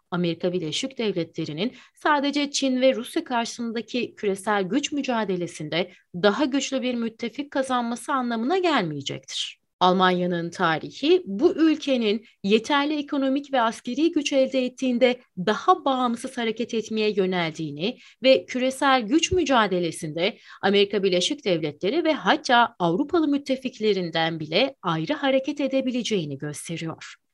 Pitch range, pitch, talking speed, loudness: 185-270 Hz, 235 Hz, 110 wpm, -24 LUFS